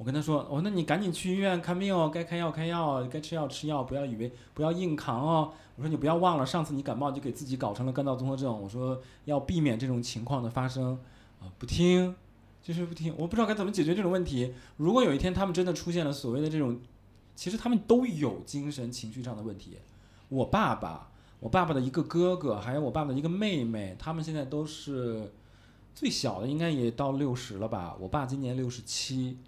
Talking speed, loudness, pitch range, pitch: 355 characters per minute, -31 LUFS, 120-165 Hz, 140 Hz